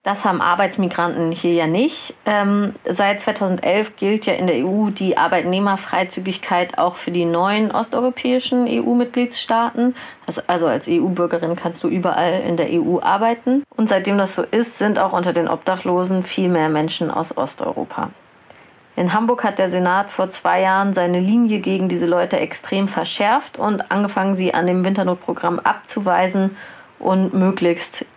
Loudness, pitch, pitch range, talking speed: -19 LUFS, 190 Hz, 180-215 Hz, 150 wpm